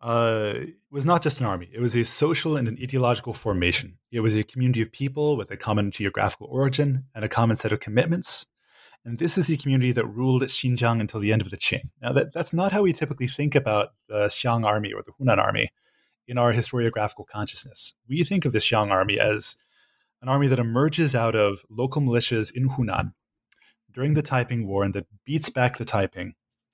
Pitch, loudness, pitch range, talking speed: 120 Hz, -24 LUFS, 110-135 Hz, 210 wpm